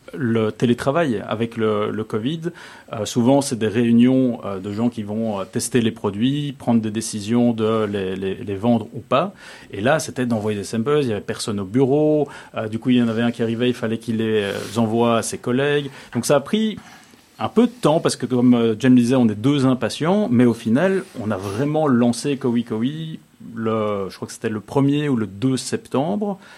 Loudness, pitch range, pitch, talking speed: -20 LUFS, 110-135 Hz, 120 Hz, 225 wpm